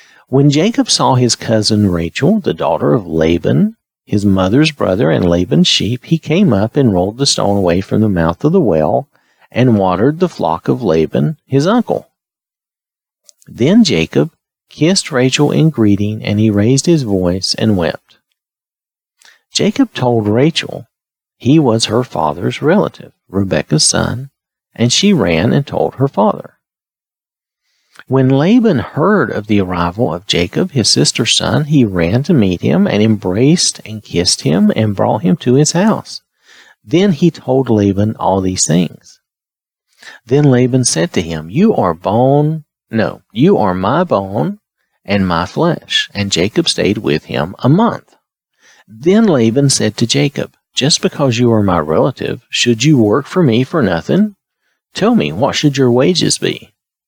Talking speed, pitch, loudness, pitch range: 160 wpm, 125 Hz, -13 LUFS, 100-150 Hz